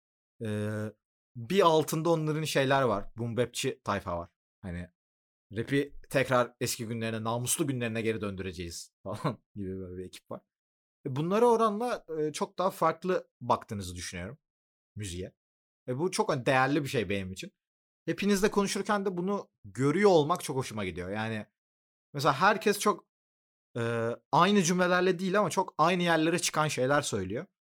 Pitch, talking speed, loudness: 125 Hz, 135 wpm, -29 LUFS